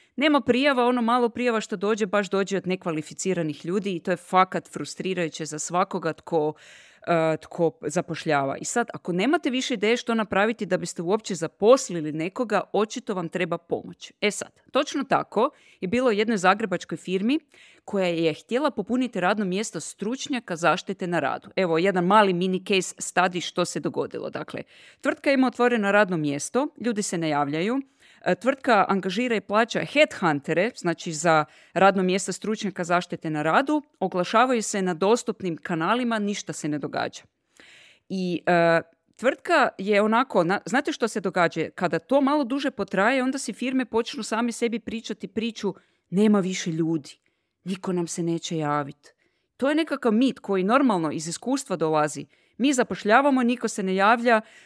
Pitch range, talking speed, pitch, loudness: 175-235 Hz, 160 wpm, 195 Hz, -24 LUFS